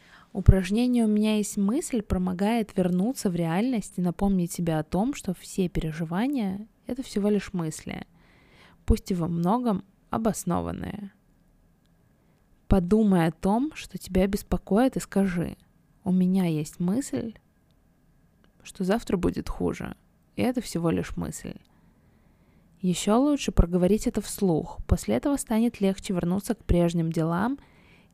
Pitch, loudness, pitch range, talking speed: 200 Hz, -26 LUFS, 180-220 Hz, 130 wpm